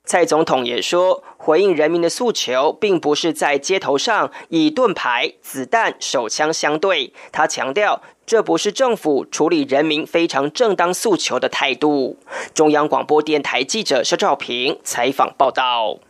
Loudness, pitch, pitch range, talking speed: -17 LUFS, 165 Hz, 150-220 Hz, 240 characters per minute